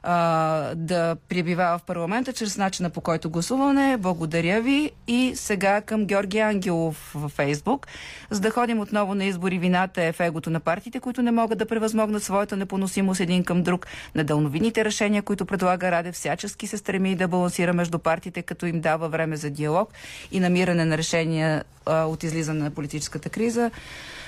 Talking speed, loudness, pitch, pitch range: 165 wpm, -24 LUFS, 180 Hz, 165-210 Hz